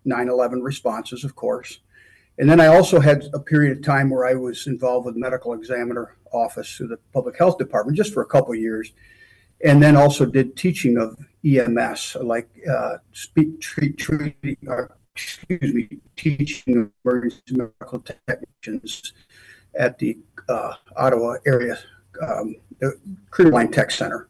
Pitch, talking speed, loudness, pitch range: 130 Hz, 160 wpm, -20 LUFS, 120-145 Hz